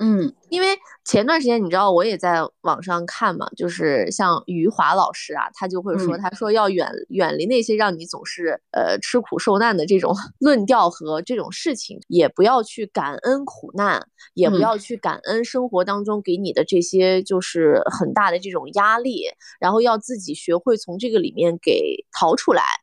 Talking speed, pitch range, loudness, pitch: 275 characters per minute, 180-250 Hz, -20 LUFS, 210 Hz